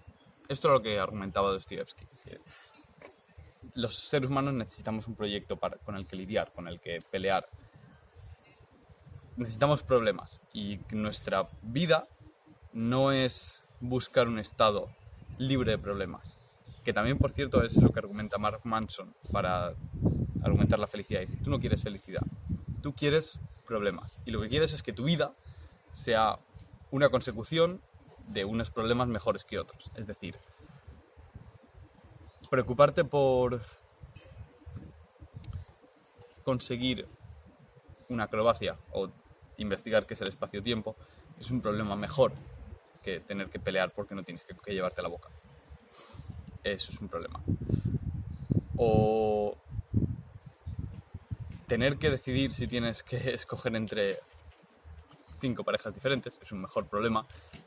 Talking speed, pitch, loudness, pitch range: 125 wpm, 110 Hz, -31 LUFS, 100-125 Hz